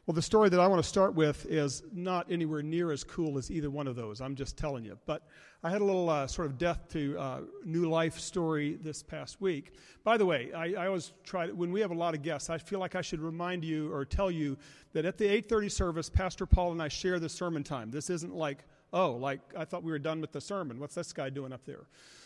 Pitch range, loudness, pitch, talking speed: 150-180 Hz, -33 LUFS, 165 Hz, 265 wpm